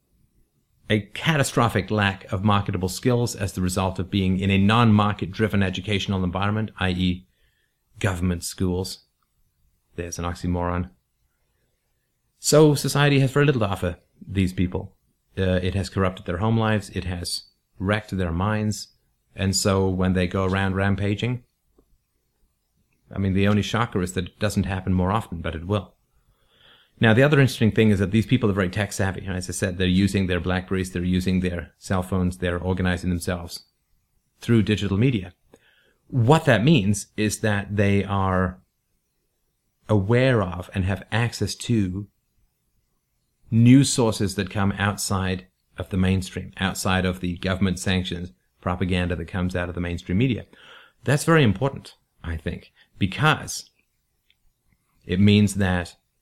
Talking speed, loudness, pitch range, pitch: 150 wpm, -23 LUFS, 90-105 Hz, 95 Hz